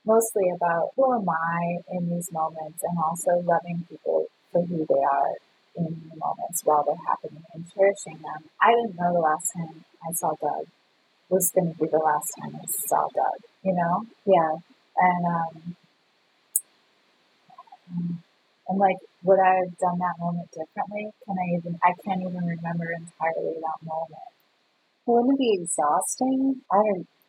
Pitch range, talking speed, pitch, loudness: 165-190 Hz, 165 wpm, 175 Hz, -25 LUFS